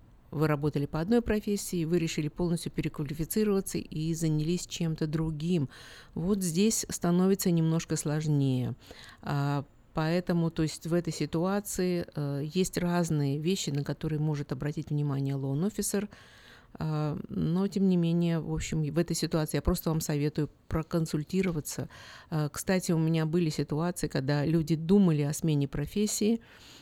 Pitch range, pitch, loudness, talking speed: 150-175 Hz, 160 Hz, -30 LUFS, 140 wpm